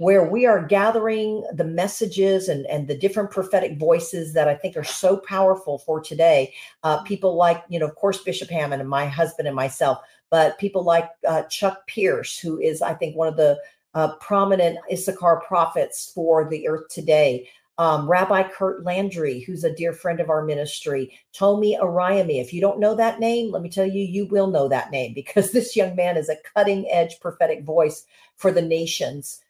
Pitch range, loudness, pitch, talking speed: 155-195 Hz, -21 LUFS, 175 Hz, 195 wpm